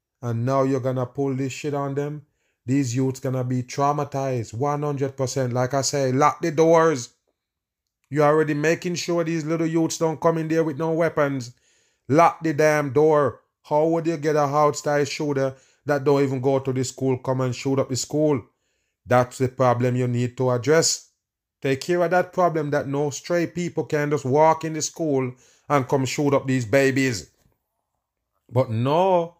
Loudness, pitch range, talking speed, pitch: -22 LUFS, 130-155 Hz, 185 wpm, 145 Hz